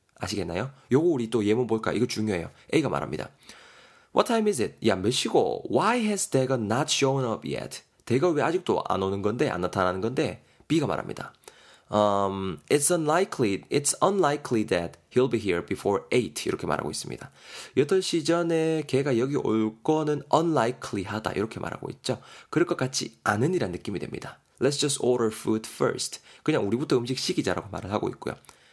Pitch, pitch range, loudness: 130 Hz, 110-155 Hz, -26 LUFS